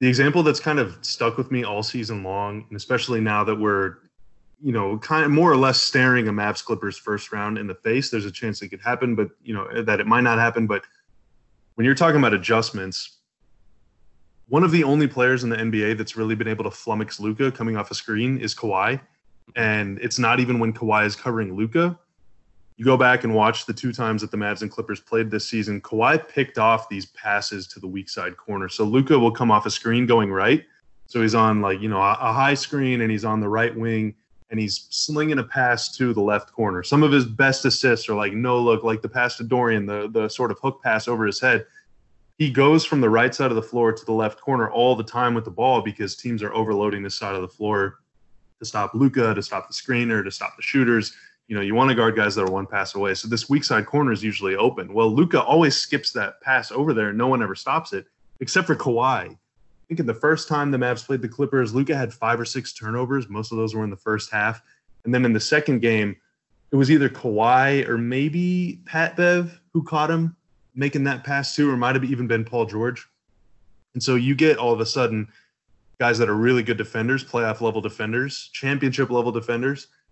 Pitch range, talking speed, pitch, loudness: 105-130 Hz, 235 wpm, 115 Hz, -22 LUFS